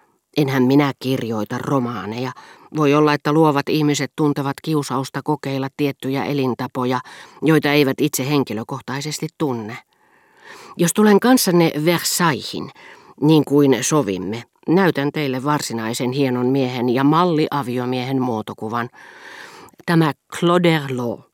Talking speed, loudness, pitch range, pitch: 105 wpm, -19 LUFS, 125-155 Hz, 140 Hz